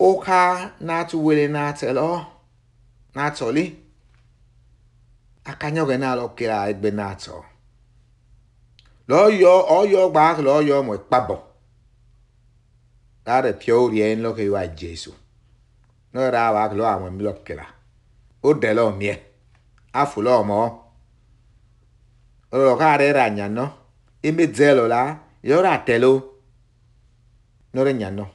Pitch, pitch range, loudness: 120 Hz, 115-135 Hz, -19 LUFS